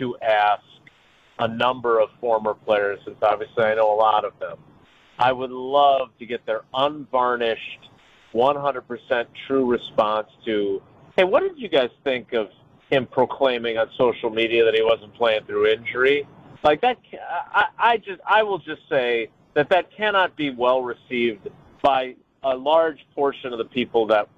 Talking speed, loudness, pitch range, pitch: 160 wpm, -22 LUFS, 115-145 Hz, 125 Hz